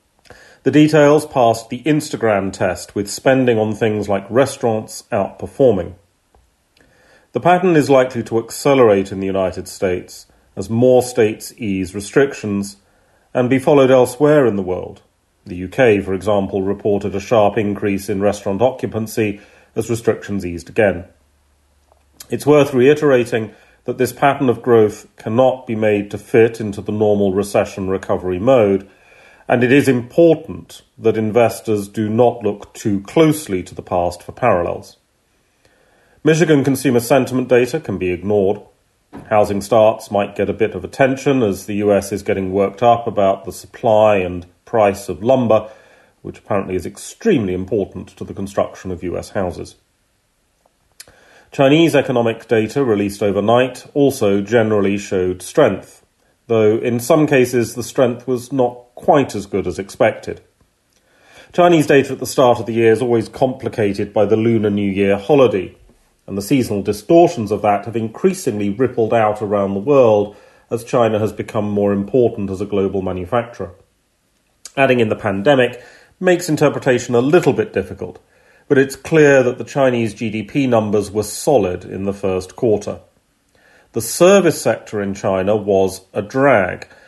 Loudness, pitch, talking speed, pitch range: -16 LUFS, 110 Hz, 150 wpm, 100-125 Hz